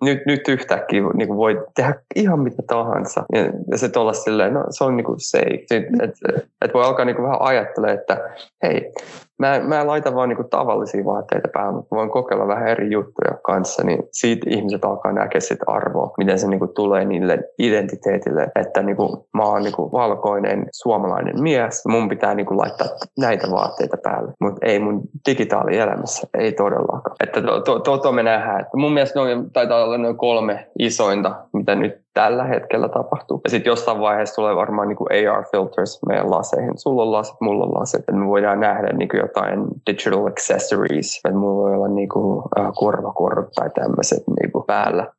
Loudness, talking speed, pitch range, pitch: -19 LUFS, 180 wpm, 105-140 Hz, 115 Hz